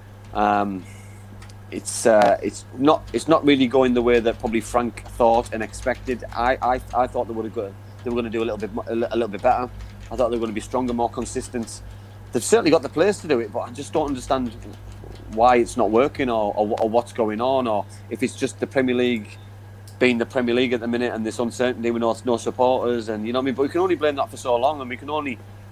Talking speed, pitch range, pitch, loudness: 255 wpm, 105-125 Hz, 115 Hz, -22 LUFS